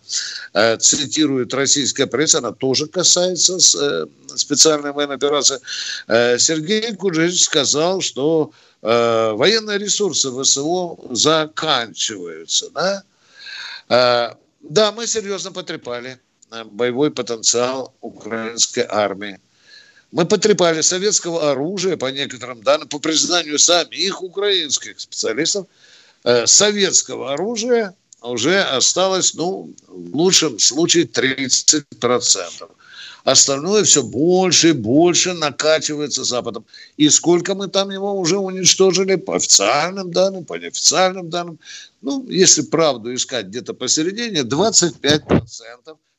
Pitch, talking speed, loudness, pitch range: 155 Hz, 95 wpm, -16 LUFS, 130-190 Hz